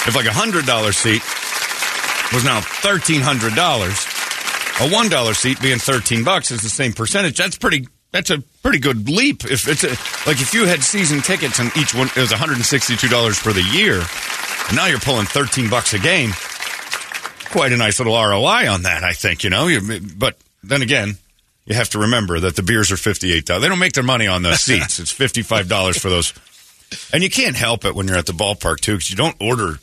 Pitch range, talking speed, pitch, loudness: 105-140 Hz, 200 wpm, 120 Hz, -16 LUFS